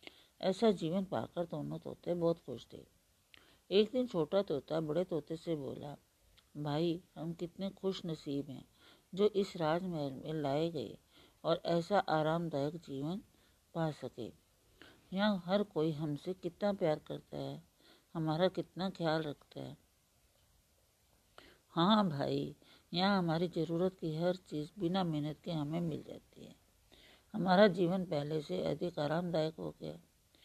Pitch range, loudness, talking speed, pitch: 145-180 Hz, -36 LUFS, 140 wpm, 165 Hz